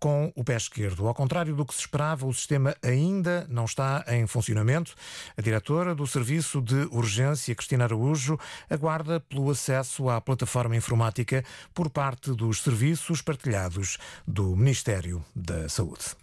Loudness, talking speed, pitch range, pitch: -28 LUFS, 150 wpm, 115-150 Hz, 130 Hz